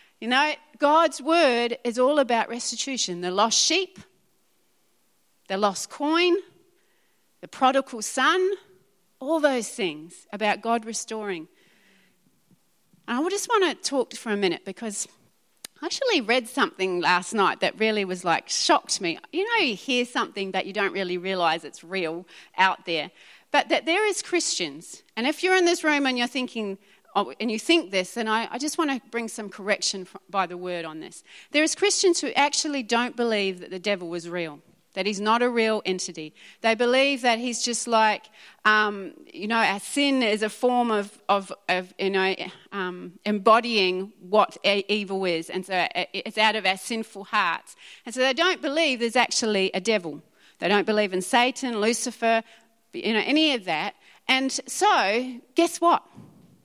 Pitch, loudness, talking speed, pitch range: 225 Hz, -24 LUFS, 175 wpm, 195-280 Hz